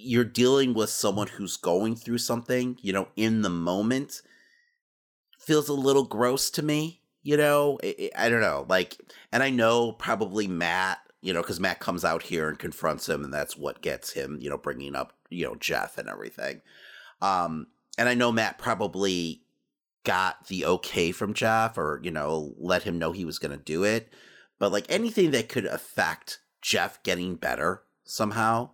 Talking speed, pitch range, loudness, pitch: 185 wpm, 90-125 Hz, -27 LUFS, 110 Hz